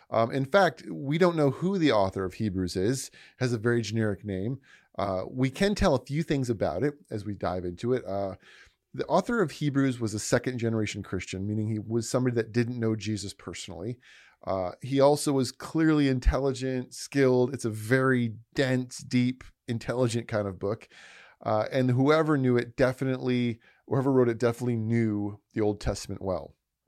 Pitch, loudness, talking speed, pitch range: 120 Hz, -28 LUFS, 180 wpm, 105-135 Hz